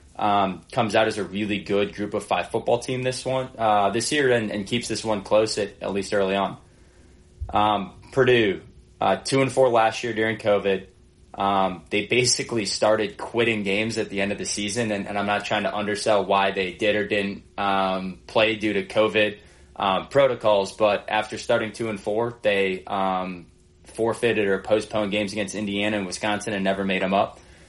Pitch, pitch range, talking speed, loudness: 105 Hz, 95-110 Hz, 195 wpm, -23 LUFS